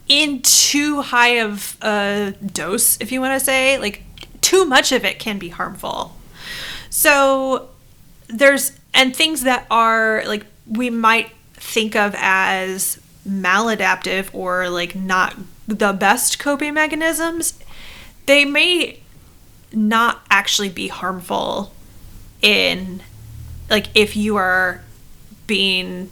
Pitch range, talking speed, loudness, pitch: 190-265 Hz, 115 wpm, -16 LUFS, 220 Hz